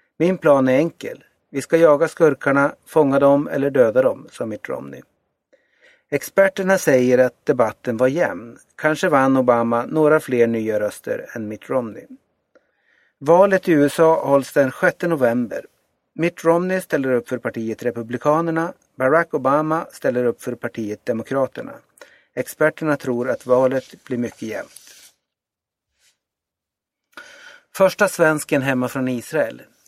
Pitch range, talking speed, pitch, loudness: 125-170 Hz, 130 wpm, 145 Hz, -19 LUFS